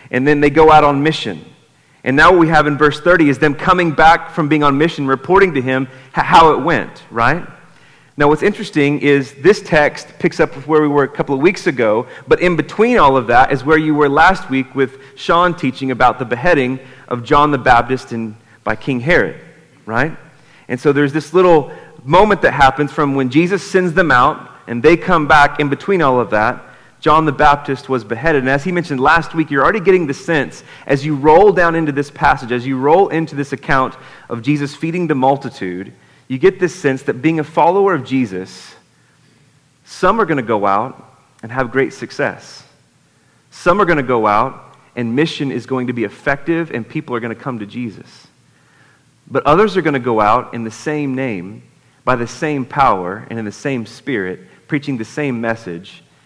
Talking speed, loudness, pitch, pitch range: 210 wpm, -14 LUFS, 145 Hz, 130-160 Hz